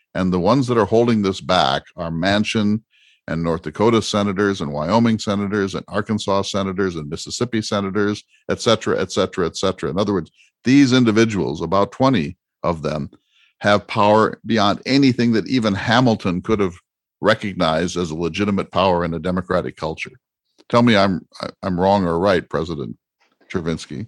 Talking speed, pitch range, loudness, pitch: 155 wpm, 90-110 Hz, -19 LUFS, 100 Hz